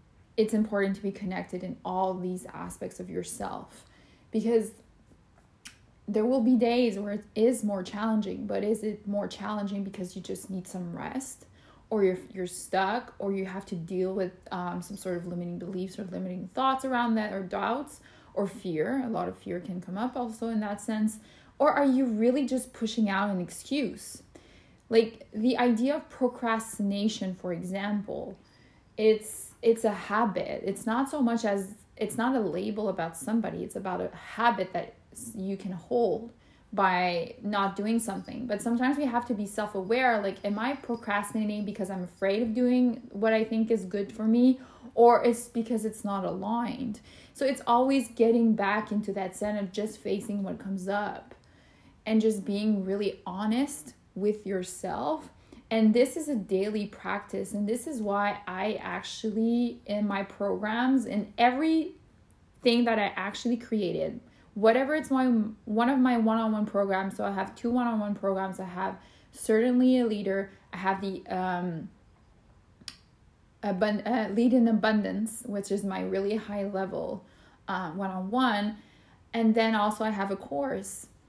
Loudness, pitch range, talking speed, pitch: -29 LUFS, 195-235 Hz, 165 wpm, 215 Hz